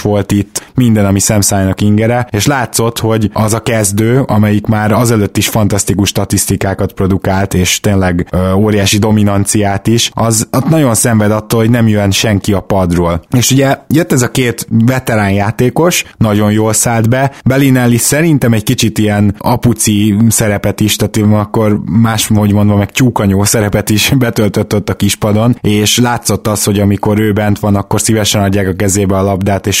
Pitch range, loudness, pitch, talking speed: 100-115 Hz, -10 LUFS, 105 Hz, 170 wpm